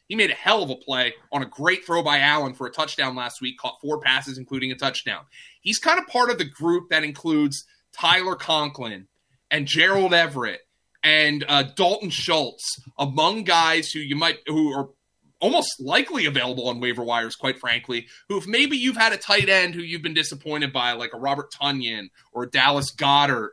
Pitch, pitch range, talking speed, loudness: 145 Hz, 130-170 Hz, 200 wpm, -21 LUFS